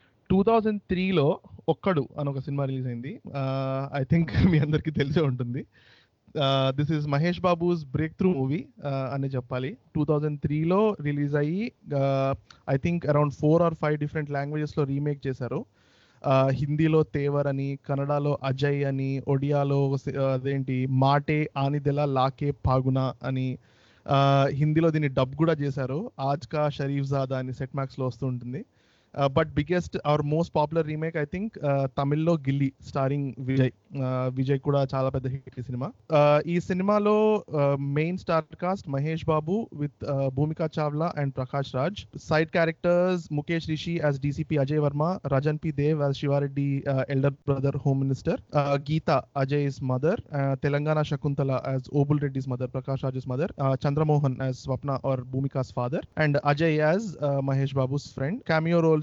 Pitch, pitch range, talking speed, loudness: 145 Hz, 135-155 Hz, 120 wpm, -26 LUFS